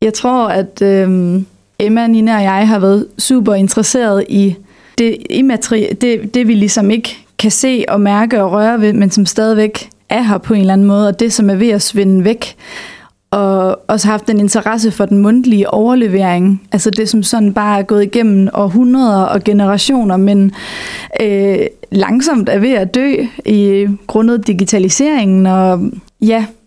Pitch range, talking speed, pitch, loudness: 200-225 Hz, 175 wpm, 210 Hz, -11 LUFS